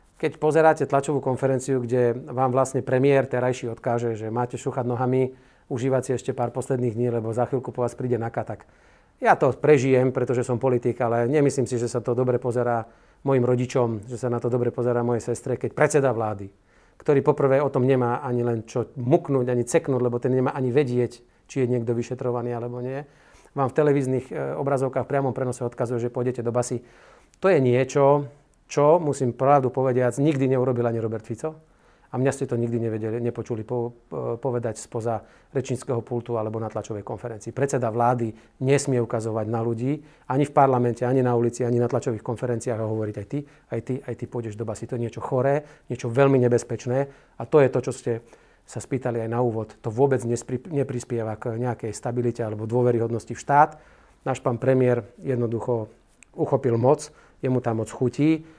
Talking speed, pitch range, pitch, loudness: 185 wpm, 120-135 Hz, 125 Hz, -24 LUFS